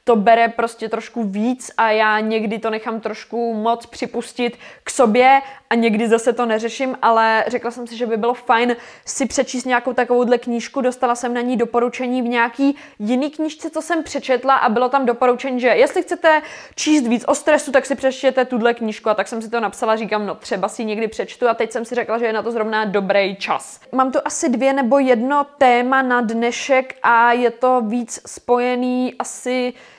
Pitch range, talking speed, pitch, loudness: 230-260 Hz, 200 wpm, 245 Hz, -18 LUFS